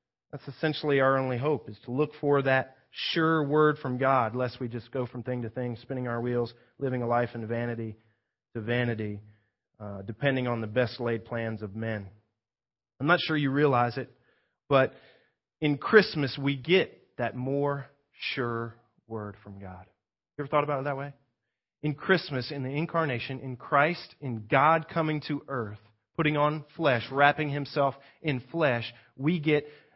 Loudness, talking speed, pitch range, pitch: -28 LUFS, 170 wpm, 115-145 Hz, 130 Hz